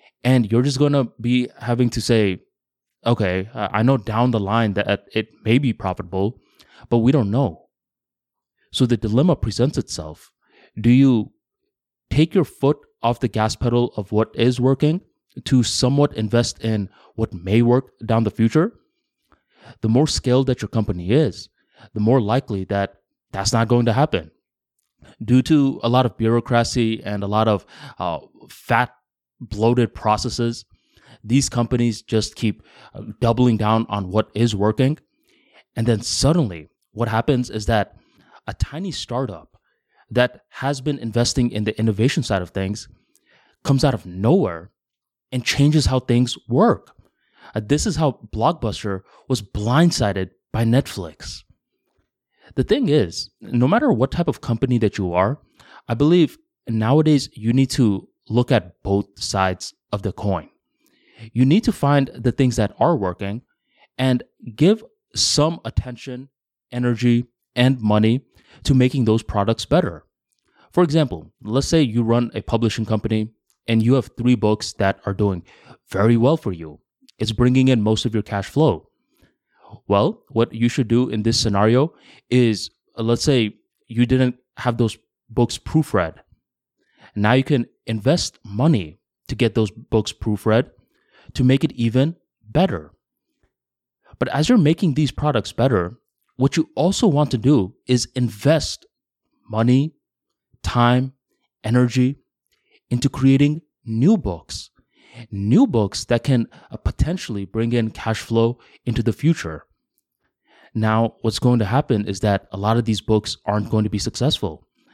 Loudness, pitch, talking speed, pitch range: -20 LUFS, 120 Hz, 150 wpm, 110-130 Hz